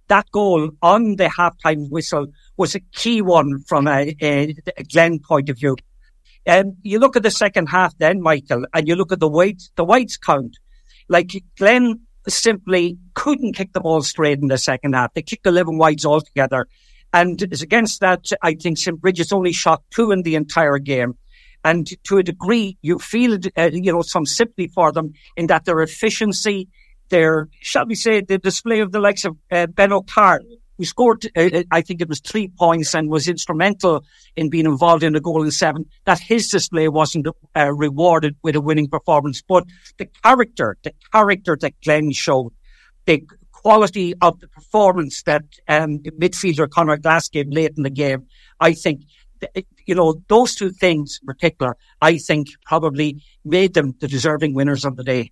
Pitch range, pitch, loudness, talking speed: 155-190 Hz, 170 Hz, -17 LUFS, 190 wpm